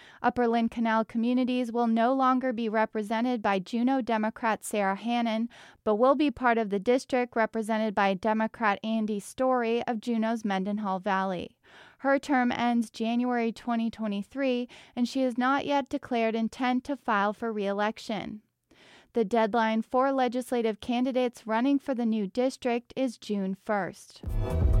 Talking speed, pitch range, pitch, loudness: 145 wpm, 220-250 Hz, 230 Hz, -28 LUFS